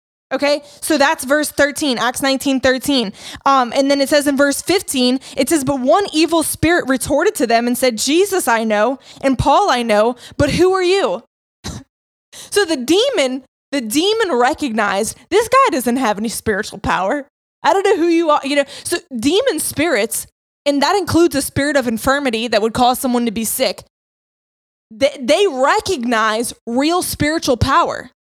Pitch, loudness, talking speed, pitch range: 280 Hz, -16 LUFS, 175 wpm, 245-320 Hz